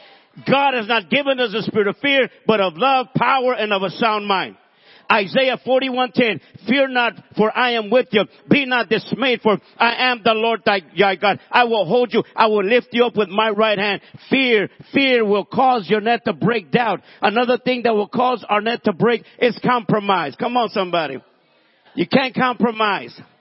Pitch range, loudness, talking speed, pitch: 205-250 Hz, -18 LUFS, 200 wpm, 225 Hz